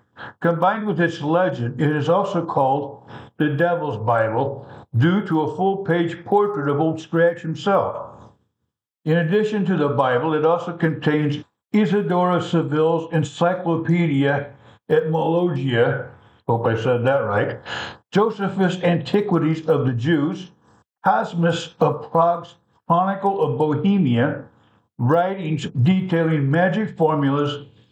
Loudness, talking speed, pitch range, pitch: -20 LUFS, 110 wpm, 145-175 Hz, 160 Hz